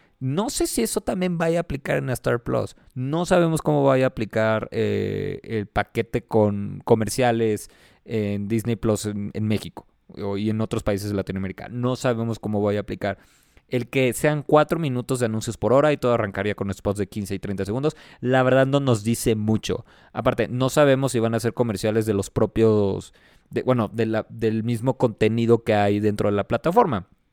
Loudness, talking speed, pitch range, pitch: -23 LUFS, 195 wpm, 105-130 Hz, 115 Hz